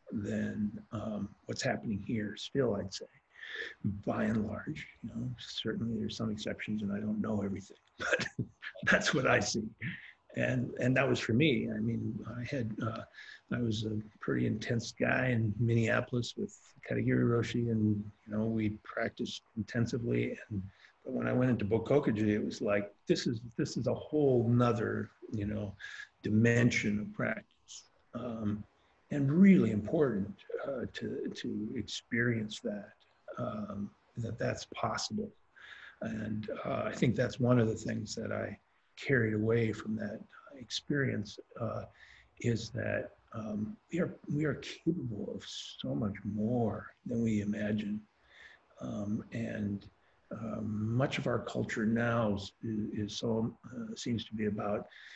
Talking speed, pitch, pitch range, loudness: 150 wpm, 110 Hz, 105-120 Hz, -34 LUFS